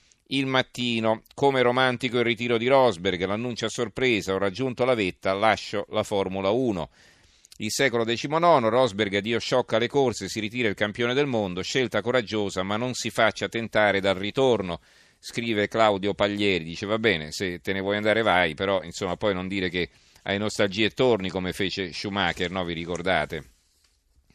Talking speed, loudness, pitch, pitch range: 170 wpm, -25 LUFS, 105 Hz, 95-120 Hz